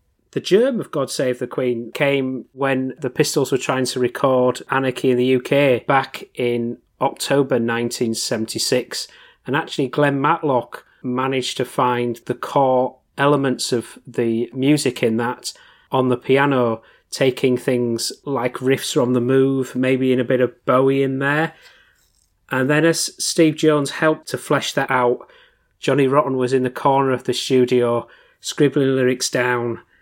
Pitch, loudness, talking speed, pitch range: 130 Hz, -19 LUFS, 155 wpm, 125-140 Hz